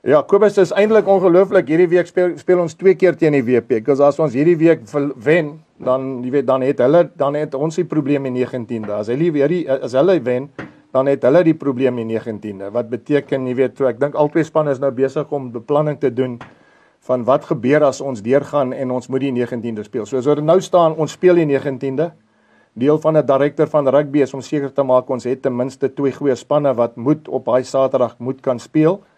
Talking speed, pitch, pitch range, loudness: 230 wpm, 140 Hz, 130-155 Hz, -17 LUFS